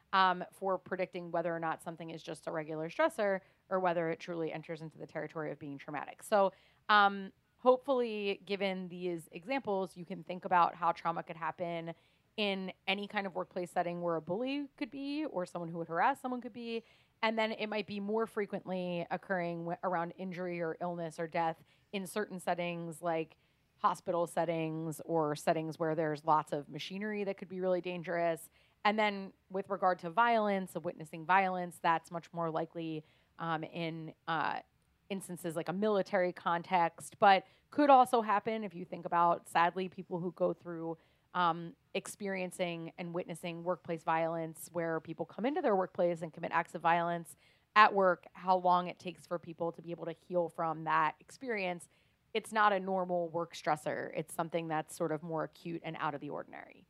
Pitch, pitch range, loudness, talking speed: 175 Hz, 165-190 Hz, -35 LUFS, 185 wpm